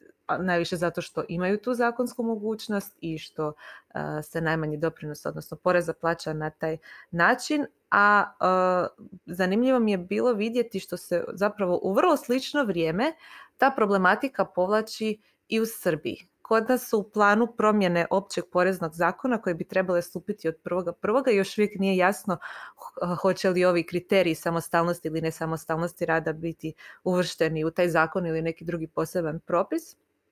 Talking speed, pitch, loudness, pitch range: 150 wpm, 185 Hz, -26 LUFS, 170-220 Hz